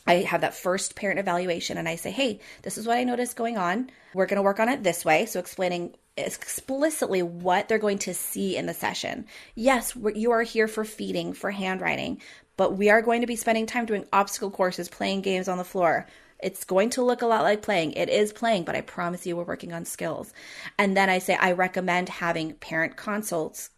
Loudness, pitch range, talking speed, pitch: -26 LUFS, 180-225 Hz, 225 wpm, 195 Hz